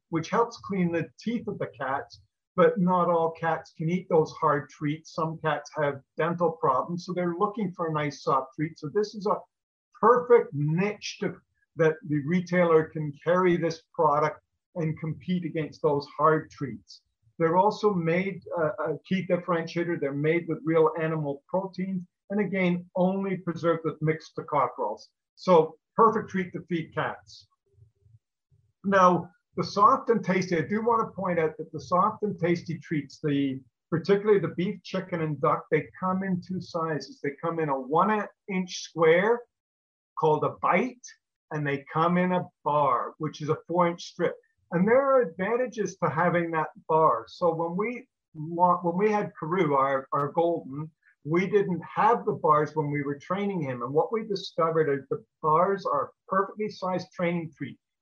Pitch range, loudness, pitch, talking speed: 155-185 Hz, -27 LUFS, 170 Hz, 175 wpm